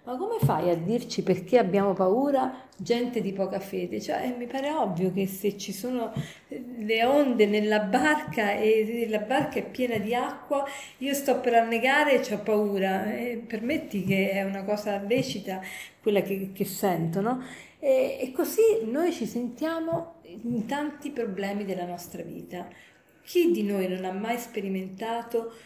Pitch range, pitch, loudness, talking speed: 195-255 Hz, 225 Hz, -27 LUFS, 160 wpm